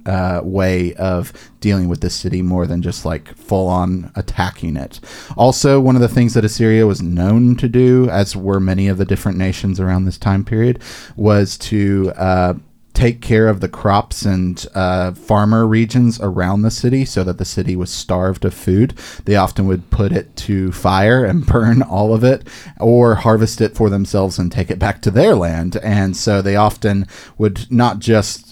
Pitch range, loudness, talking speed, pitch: 90-110 Hz, -15 LUFS, 190 wpm, 100 Hz